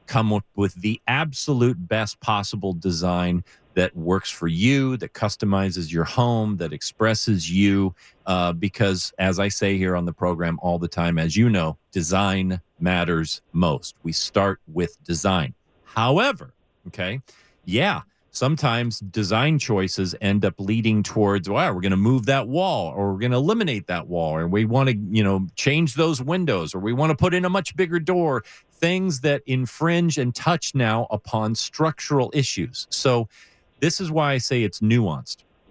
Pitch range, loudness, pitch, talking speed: 95-135 Hz, -22 LUFS, 110 Hz, 170 wpm